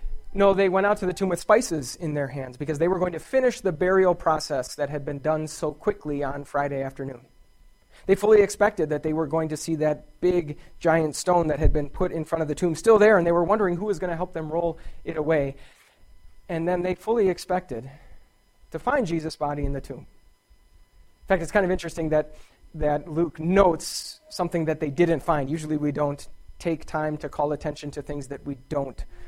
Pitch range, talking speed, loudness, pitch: 145-180 Hz, 220 wpm, -25 LUFS, 160 Hz